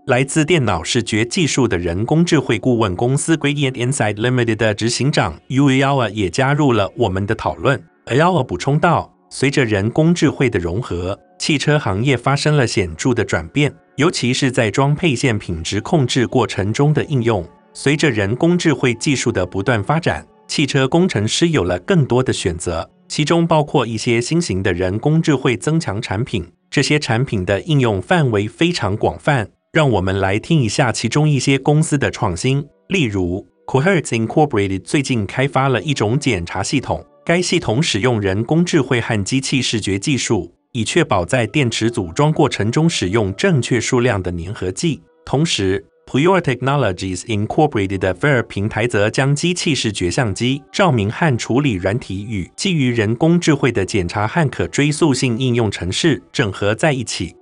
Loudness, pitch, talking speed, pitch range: -17 LUFS, 125 Hz, 330 characters per minute, 105-150 Hz